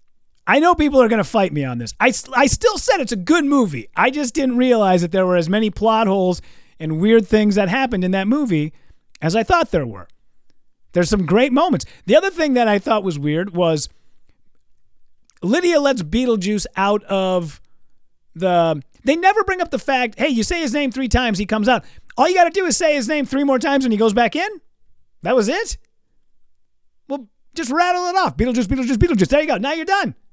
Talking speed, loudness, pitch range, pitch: 220 wpm, -17 LUFS, 185-285 Hz, 230 Hz